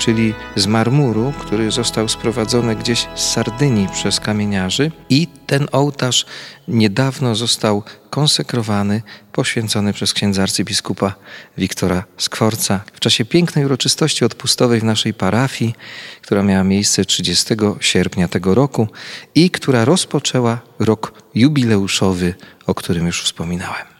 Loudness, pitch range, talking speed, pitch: -16 LUFS, 100-130 Hz, 120 wpm, 110 Hz